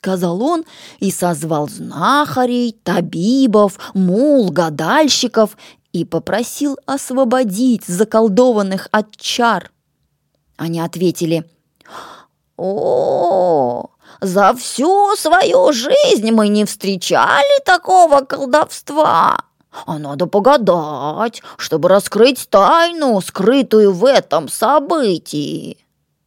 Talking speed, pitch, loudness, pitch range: 80 wpm, 220 Hz, -14 LUFS, 180-275 Hz